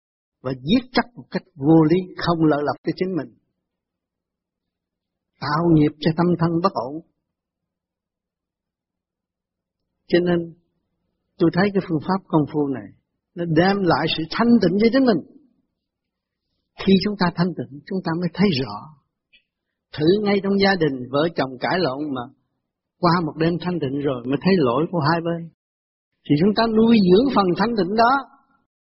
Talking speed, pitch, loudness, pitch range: 165 wpm, 170 Hz, -20 LUFS, 145-195 Hz